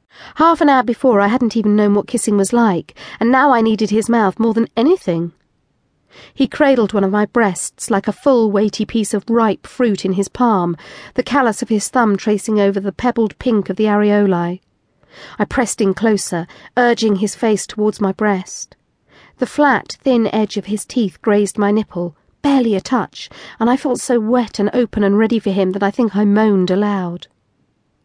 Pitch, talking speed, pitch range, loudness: 215 Hz, 195 wpm, 200-240 Hz, -16 LUFS